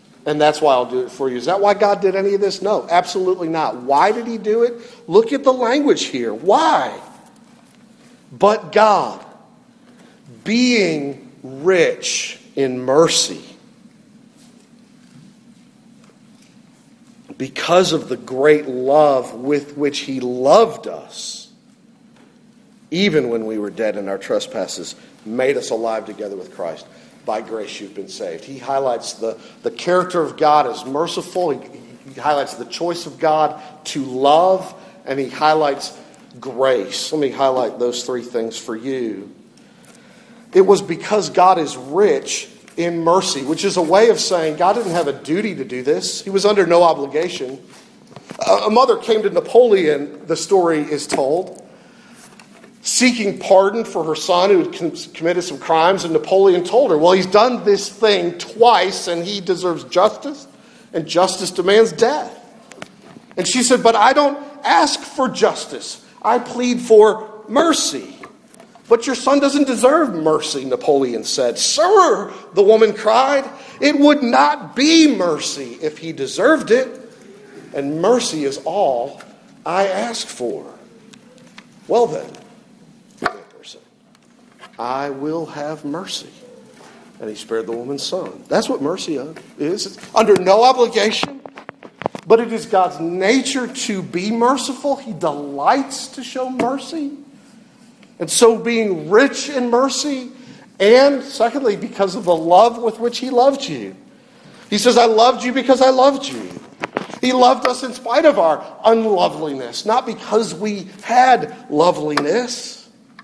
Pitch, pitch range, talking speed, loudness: 220 Hz, 165-245 Hz, 145 wpm, -17 LUFS